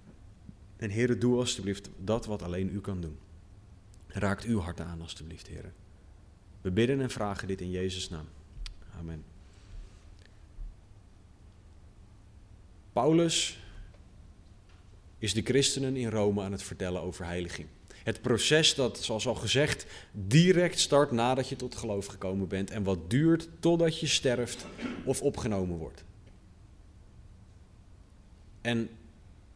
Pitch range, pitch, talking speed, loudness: 90-115 Hz, 100 Hz, 120 wpm, -30 LUFS